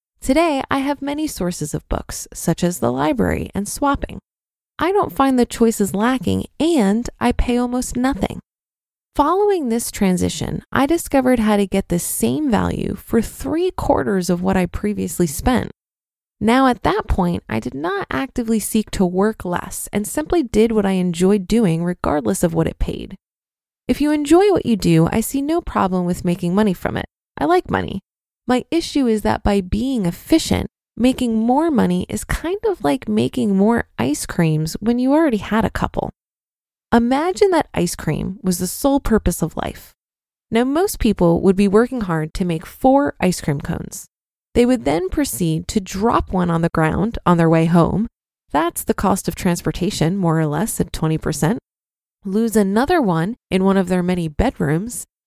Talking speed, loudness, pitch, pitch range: 180 wpm, -19 LUFS, 215 Hz, 180-265 Hz